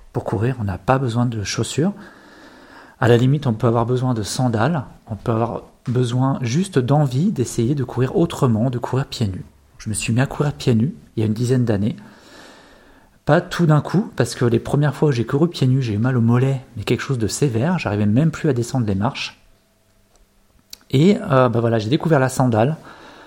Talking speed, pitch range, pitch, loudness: 220 wpm, 115-150 Hz, 130 Hz, -19 LUFS